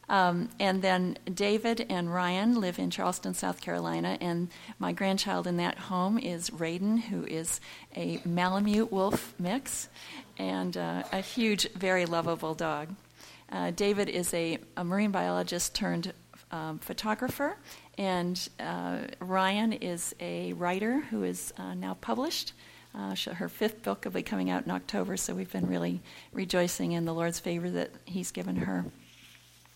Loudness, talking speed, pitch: -32 LUFS, 155 wpm, 180 Hz